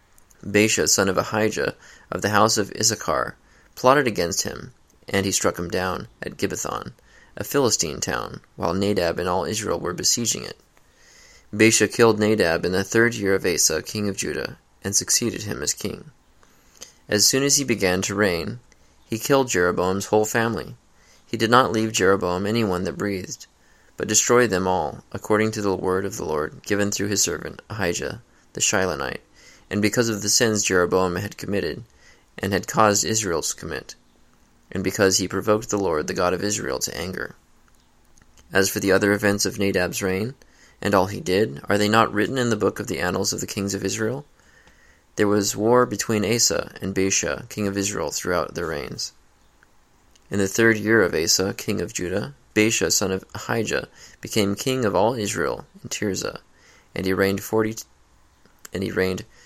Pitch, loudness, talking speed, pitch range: 100 Hz, -22 LUFS, 180 wpm, 95-110 Hz